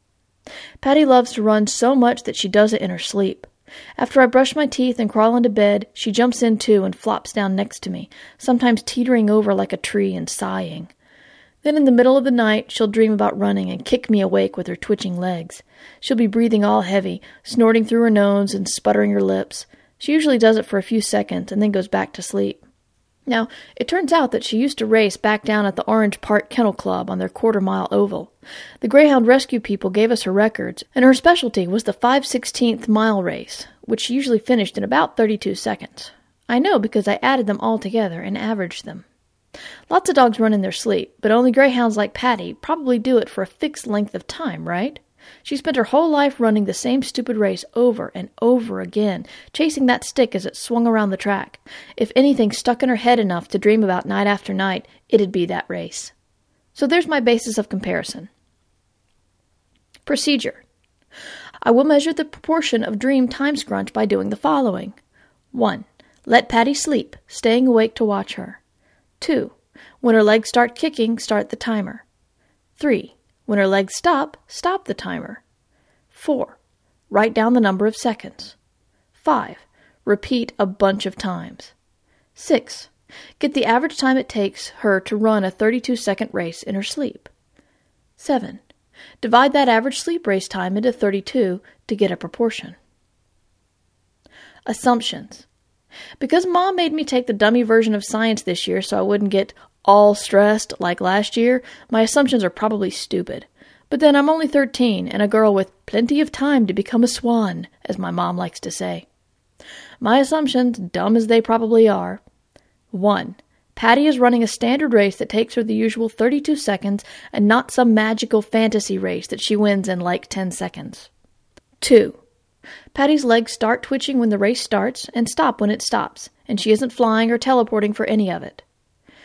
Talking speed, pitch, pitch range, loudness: 190 wpm, 225 Hz, 205-250 Hz, -18 LUFS